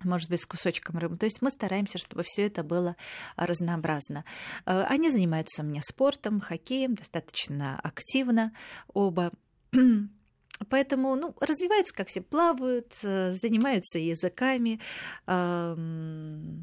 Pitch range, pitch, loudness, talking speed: 170-250 Hz, 190 Hz, -29 LUFS, 110 wpm